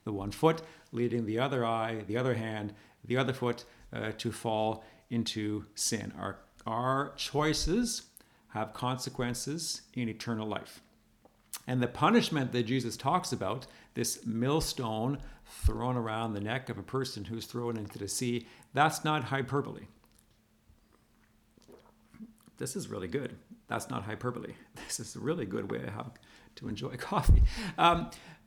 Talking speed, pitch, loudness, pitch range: 145 wpm, 120 Hz, -33 LUFS, 110-135 Hz